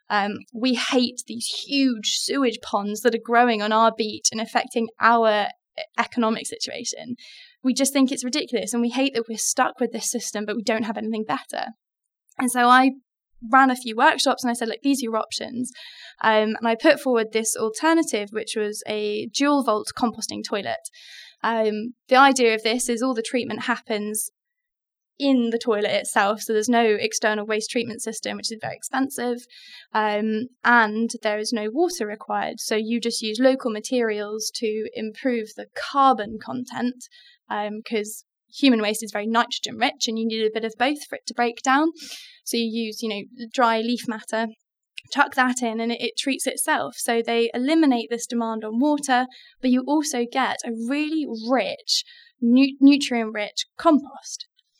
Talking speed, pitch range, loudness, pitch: 175 wpm, 220-265 Hz, -22 LUFS, 235 Hz